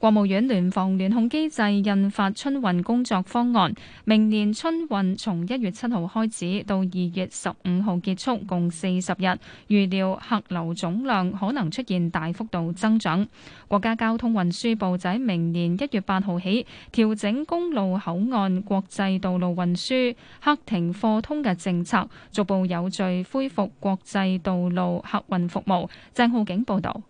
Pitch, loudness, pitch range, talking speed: 195 Hz, -24 LUFS, 185-225 Hz, 240 characters per minute